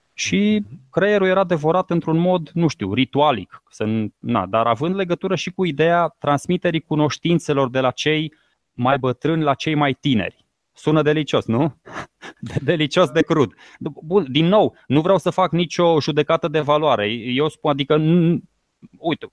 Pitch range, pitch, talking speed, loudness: 140-170 Hz, 155 Hz, 155 wpm, -19 LUFS